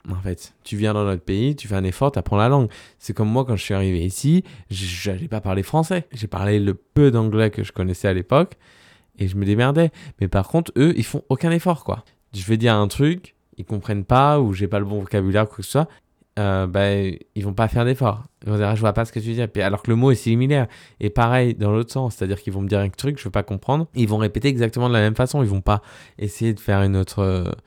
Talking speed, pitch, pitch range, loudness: 275 wpm, 110 Hz, 100-125 Hz, -21 LUFS